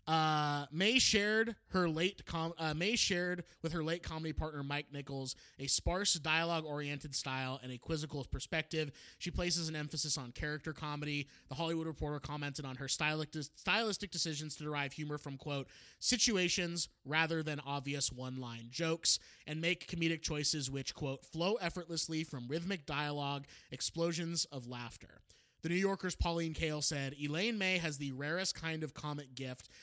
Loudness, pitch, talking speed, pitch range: -36 LUFS, 155 Hz, 160 wpm, 140-170 Hz